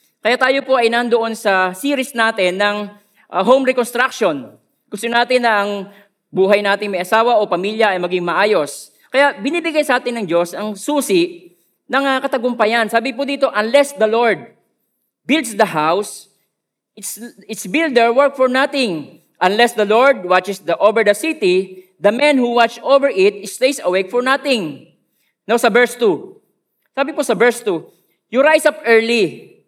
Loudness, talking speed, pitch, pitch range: -15 LUFS, 165 wpm, 235 Hz, 205-270 Hz